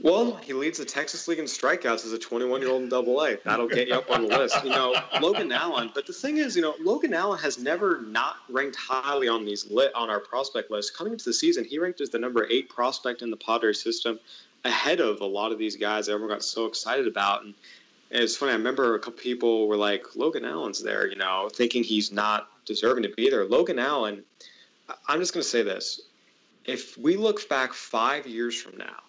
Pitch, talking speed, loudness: 120 Hz, 230 wpm, -26 LUFS